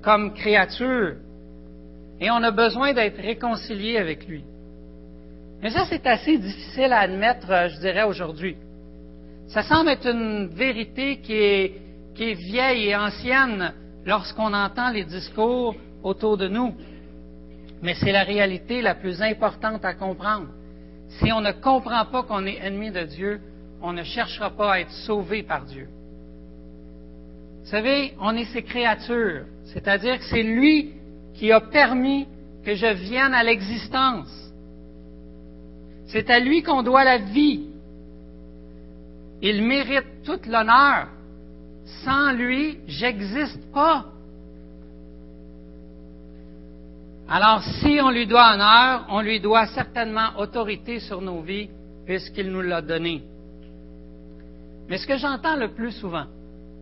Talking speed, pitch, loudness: 130 wpm, 200 Hz, -22 LUFS